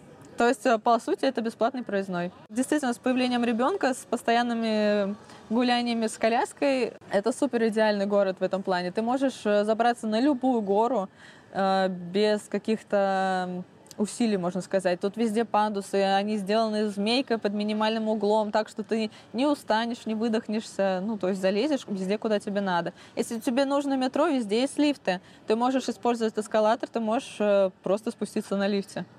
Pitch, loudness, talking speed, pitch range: 220 Hz, -26 LUFS, 155 wpm, 200-240 Hz